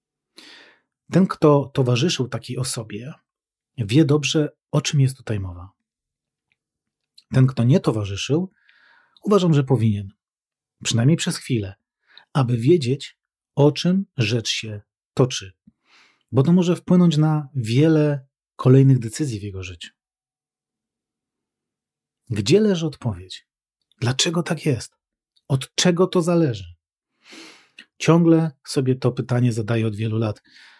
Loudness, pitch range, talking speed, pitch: -20 LUFS, 115-155 Hz, 115 wpm, 135 Hz